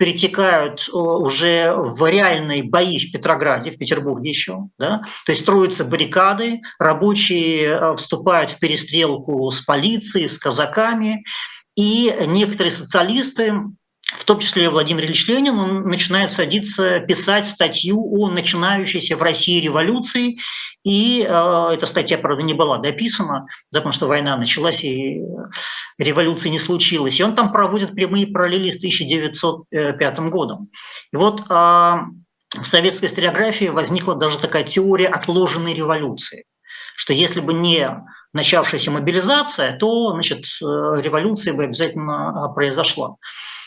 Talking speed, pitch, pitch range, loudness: 120 wpm, 175 Hz, 155-200 Hz, -17 LUFS